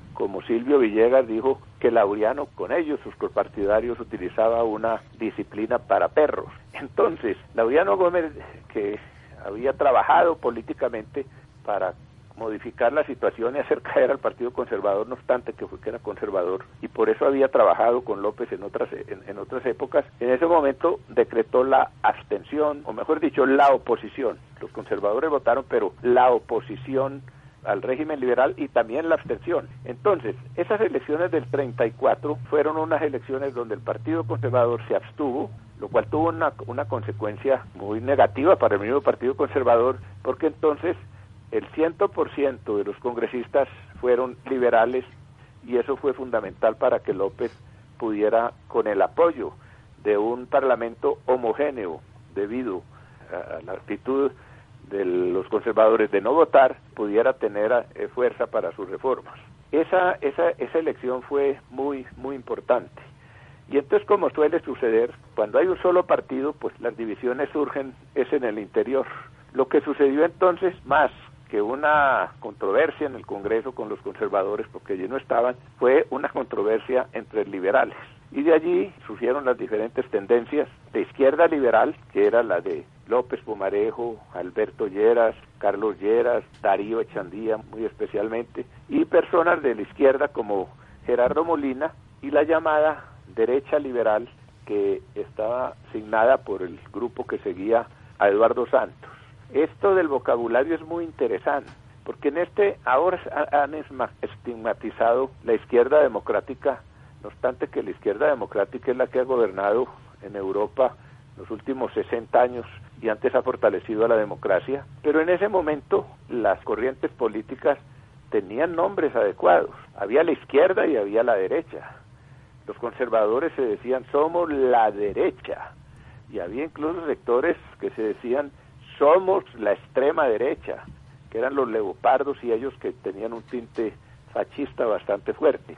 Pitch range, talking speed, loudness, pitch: 125-205 Hz, 145 wpm, -24 LUFS, 140 Hz